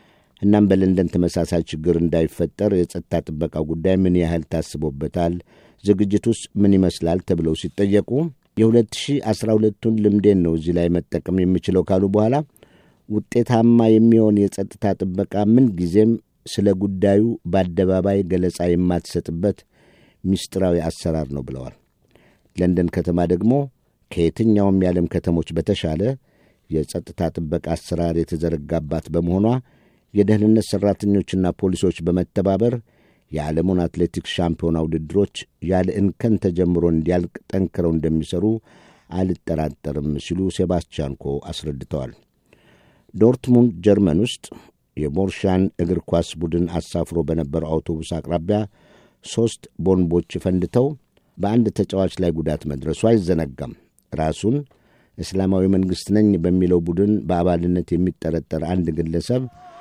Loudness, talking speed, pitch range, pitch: -20 LUFS, 100 wpm, 85-105 Hz, 90 Hz